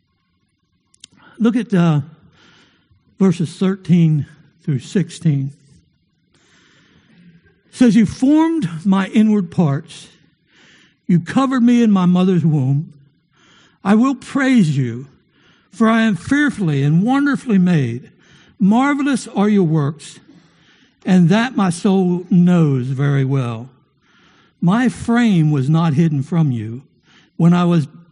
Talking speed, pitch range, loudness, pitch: 115 wpm, 150-210 Hz, -16 LUFS, 175 Hz